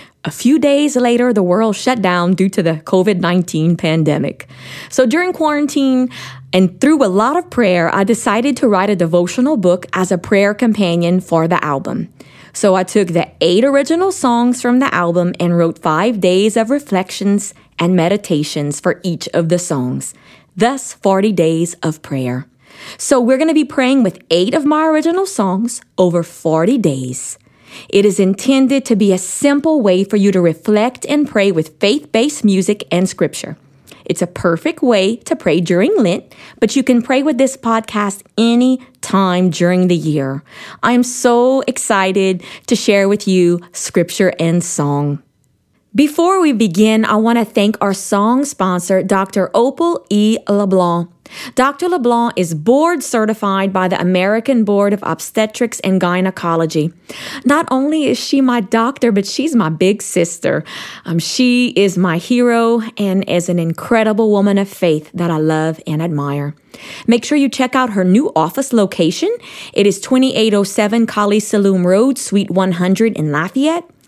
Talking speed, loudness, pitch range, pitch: 165 wpm, -14 LUFS, 175-245 Hz, 200 Hz